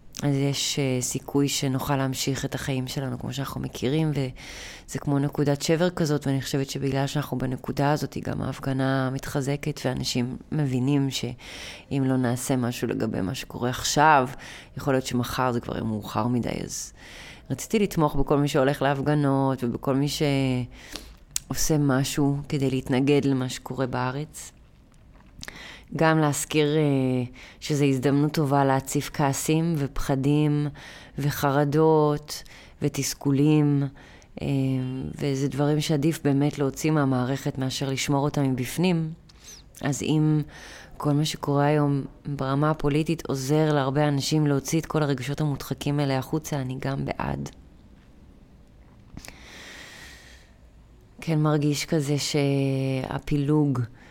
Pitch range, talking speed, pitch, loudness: 130-150 Hz, 115 wpm, 140 Hz, -25 LUFS